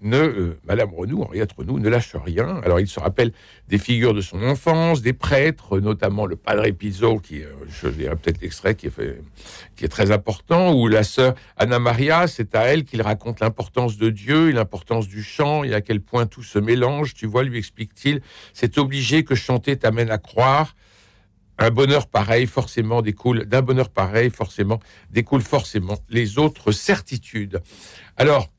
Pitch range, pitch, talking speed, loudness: 100-130 Hz, 115 Hz, 185 wpm, -20 LUFS